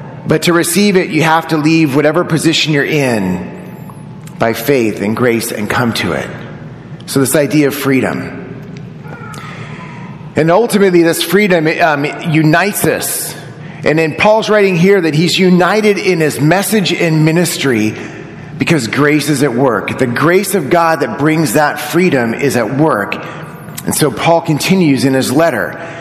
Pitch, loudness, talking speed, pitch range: 160 Hz, -12 LUFS, 155 wpm, 140-170 Hz